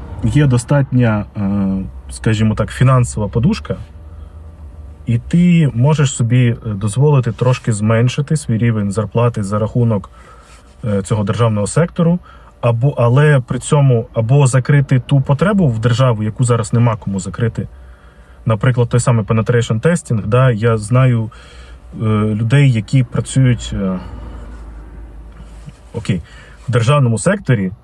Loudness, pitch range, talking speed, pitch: -15 LUFS, 105-130 Hz, 110 wpm, 115 Hz